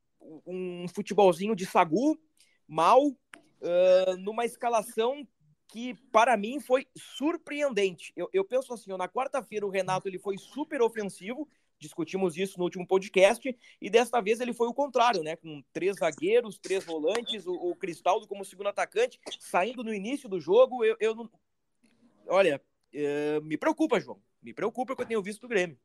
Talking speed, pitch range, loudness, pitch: 165 wpm, 185-250 Hz, -28 LUFS, 210 Hz